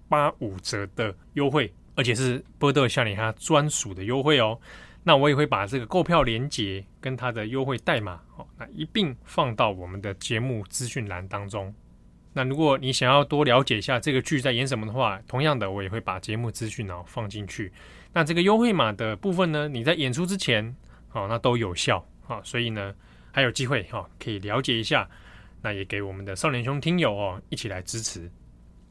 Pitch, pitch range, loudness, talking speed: 120 Hz, 100-140 Hz, -25 LUFS, 305 characters per minute